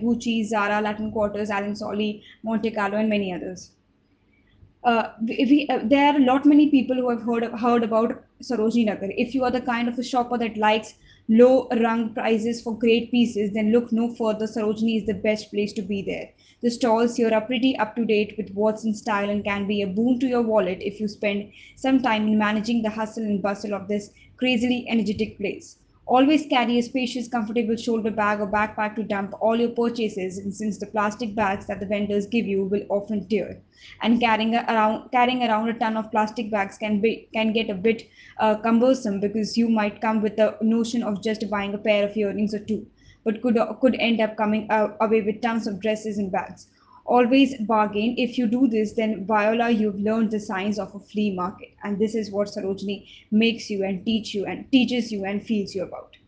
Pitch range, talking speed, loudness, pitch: 210-235 Hz, 210 wpm, -23 LUFS, 220 Hz